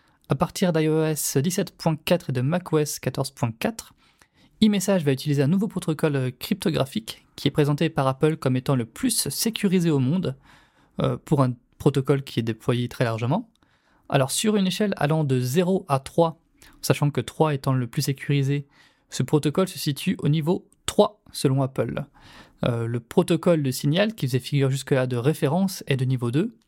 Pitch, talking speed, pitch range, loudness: 150 Hz, 170 wpm, 135-175 Hz, -24 LUFS